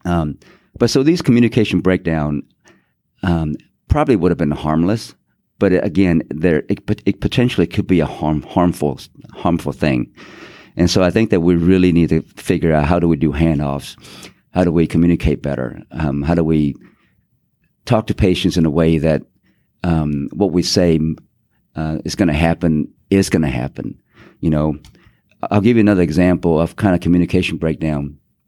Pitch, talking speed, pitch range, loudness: 85 Hz, 175 wpm, 75-95 Hz, -16 LUFS